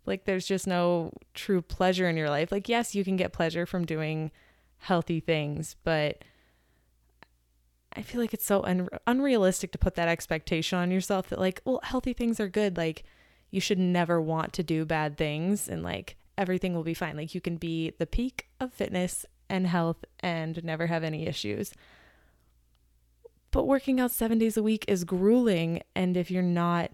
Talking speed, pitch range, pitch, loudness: 185 wpm, 160-195 Hz, 175 Hz, -29 LUFS